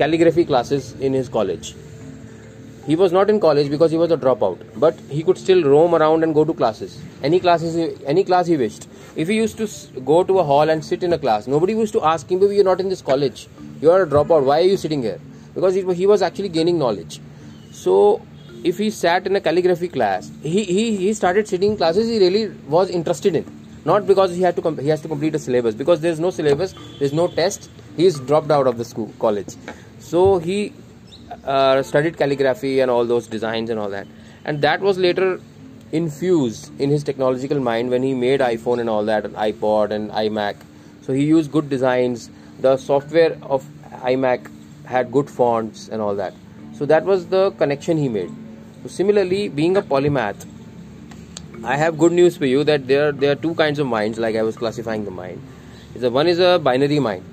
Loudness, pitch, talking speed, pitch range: -19 LUFS, 150 Hz, 210 wpm, 125-180 Hz